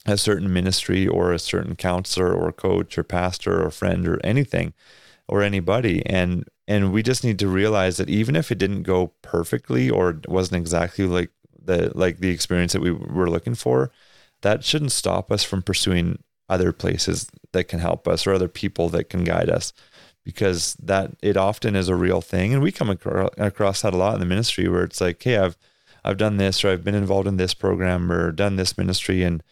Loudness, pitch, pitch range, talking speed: -22 LUFS, 95 Hz, 90-100 Hz, 205 wpm